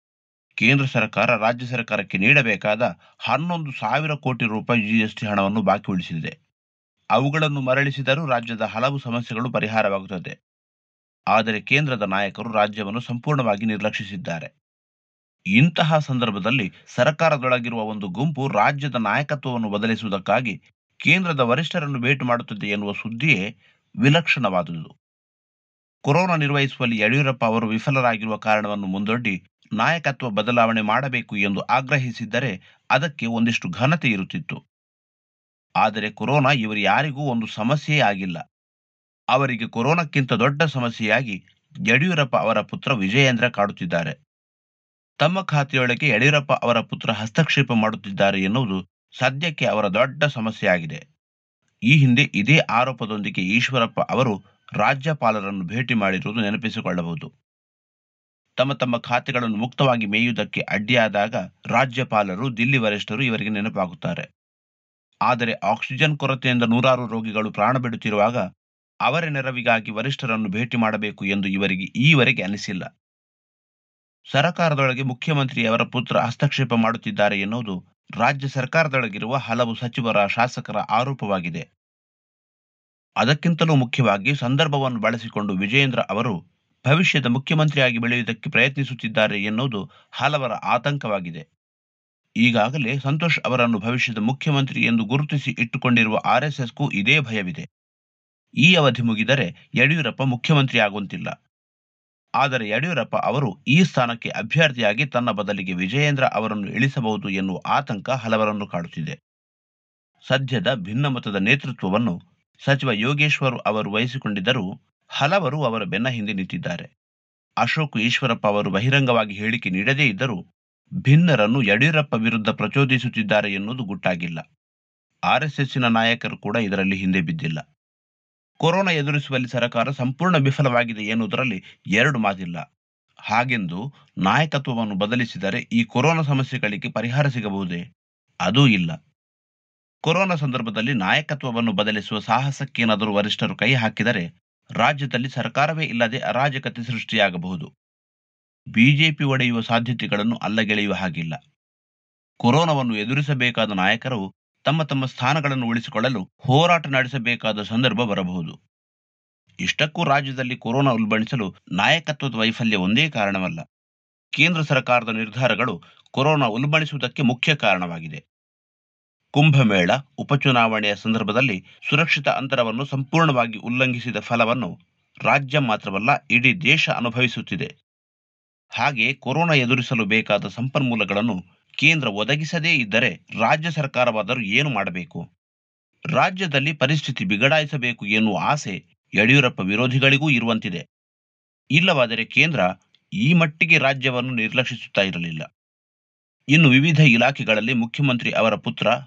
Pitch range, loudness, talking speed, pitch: 110-140 Hz, -20 LUFS, 95 wpm, 120 Hz